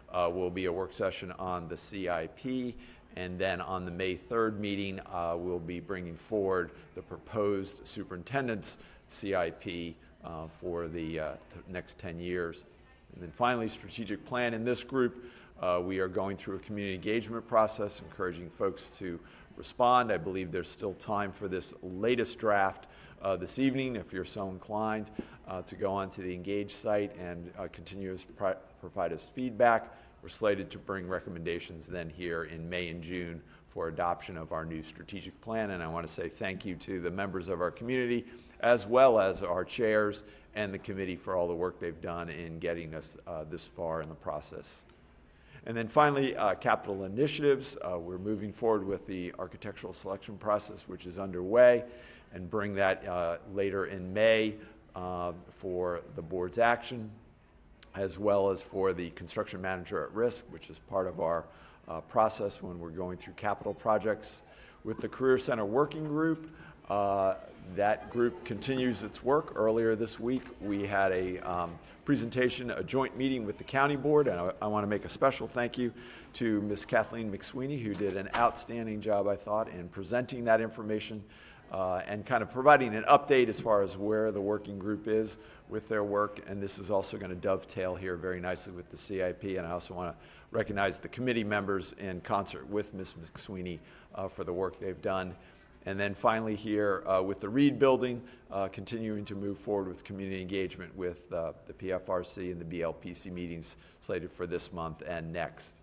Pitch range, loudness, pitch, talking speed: 90-110 Hz, -33 LUFS, 100 Hz, 185 wpm